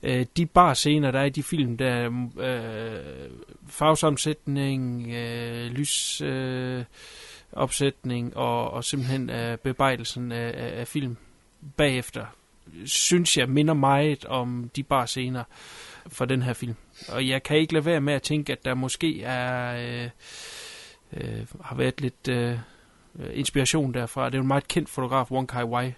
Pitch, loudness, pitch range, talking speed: 130 Hz, -26 LUFS, 120-145 Hz, 150 wpm